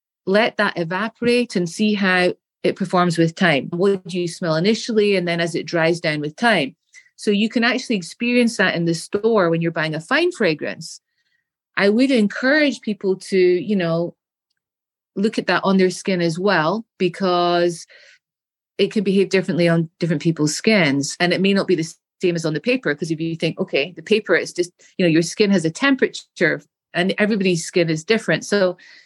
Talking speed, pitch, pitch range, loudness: 195 wpm, 185 Hz, 170-215 Hz, -19 LUFS